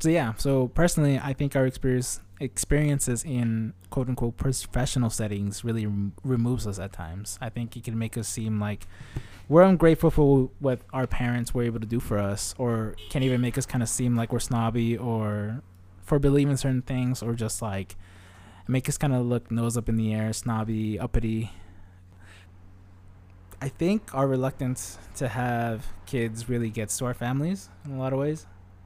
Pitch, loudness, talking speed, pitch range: 120 Hz, -27 LUFS, 185 wpm, 105-130 Hz